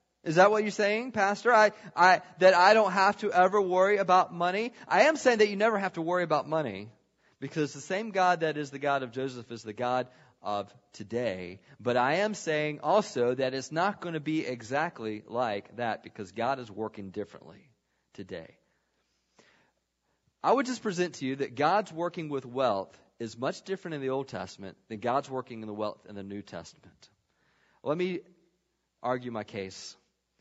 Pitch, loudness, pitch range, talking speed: 145 Hz, -28 LUFS, 115-185 Hz, 190 wpm